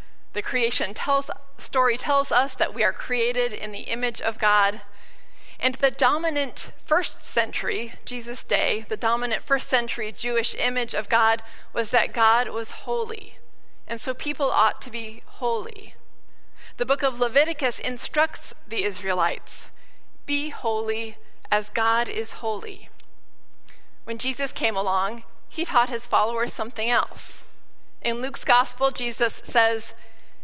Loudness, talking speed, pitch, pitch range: -24 LUFS, 140 wpm, 235 Hz, 220-265 Hz